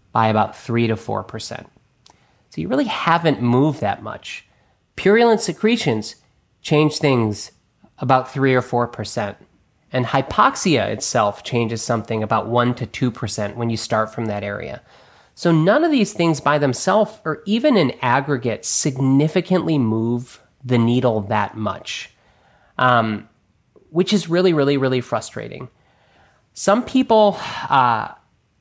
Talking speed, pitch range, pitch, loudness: 135 wpm, 115-165 Hz, 130 Hz, -19 LUFS